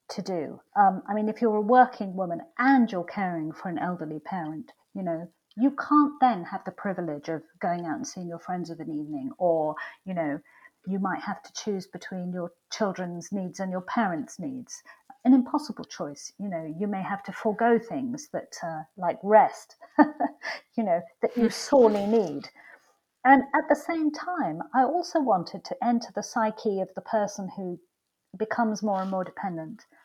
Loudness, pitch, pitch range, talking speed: -27 LUFS, 205 Hz, 180-250 Hz, 185 wpm